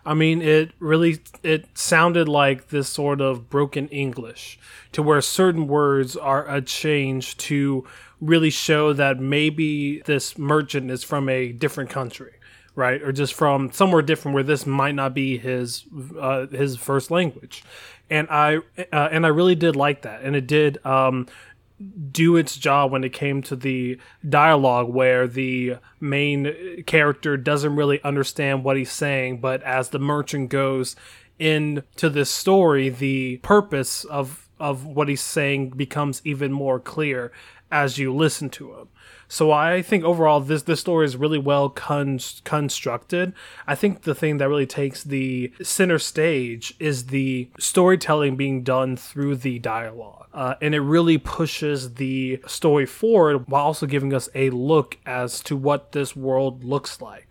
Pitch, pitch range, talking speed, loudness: 140 Hz, 130-155 Hz, 160 wpm, -21 LUFS